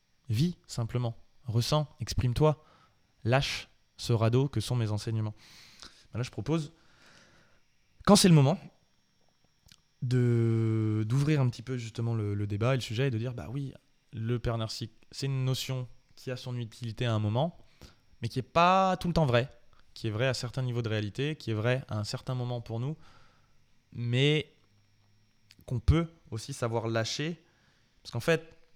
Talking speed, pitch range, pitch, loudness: 170 wpm, 110-140 Hz, 120 Hz, -30 LUFS